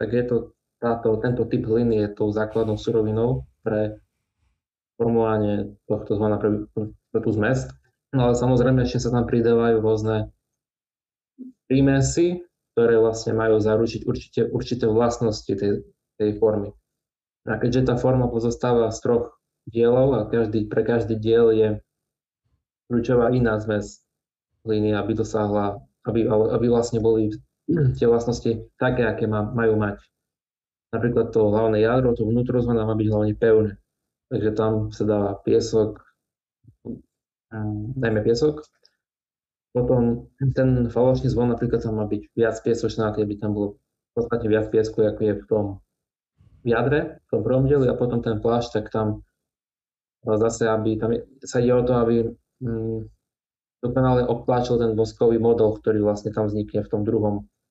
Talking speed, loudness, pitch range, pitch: 150 wpm, -22 LUFS, 110-120 Hz, 115 Hz